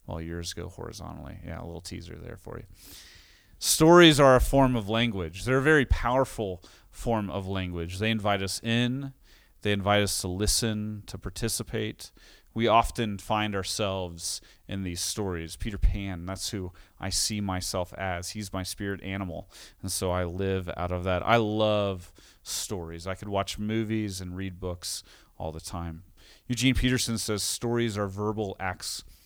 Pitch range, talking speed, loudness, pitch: 90-110 Hz, 170 wpm, -27 LUFS, 95 Hz